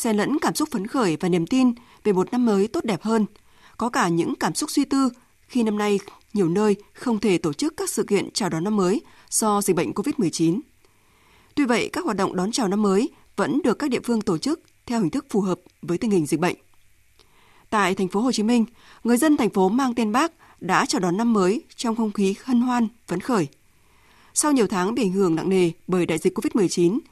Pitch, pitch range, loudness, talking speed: 215 Hz, 190-255 Hz, -23 LUFS, 235 wpm